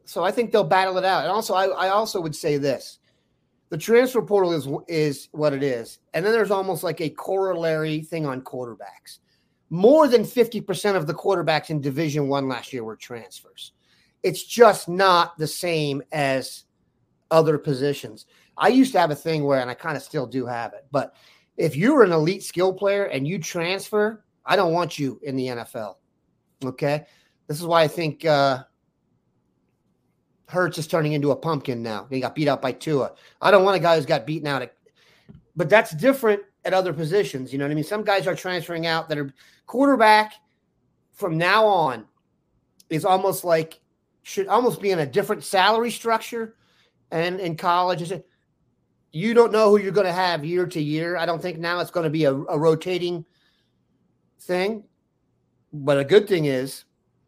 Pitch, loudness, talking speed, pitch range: 170 Hz, -22 LUFS, 190 wpm, 145-195 Hz